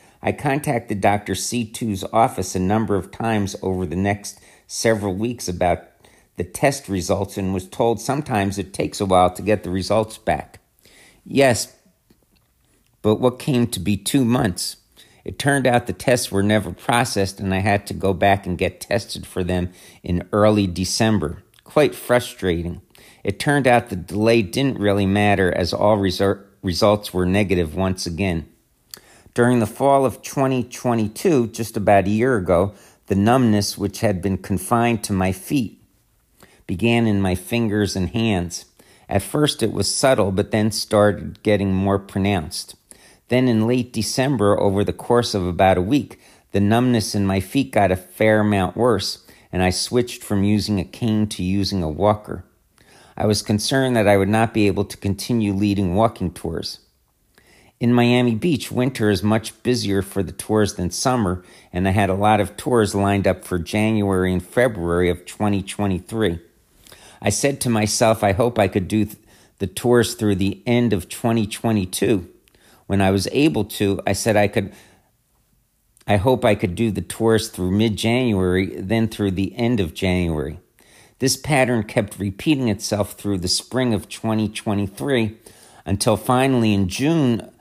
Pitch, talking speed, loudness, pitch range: 105 Hz, 165 wpm, -20 LUFS, 95-115 Hz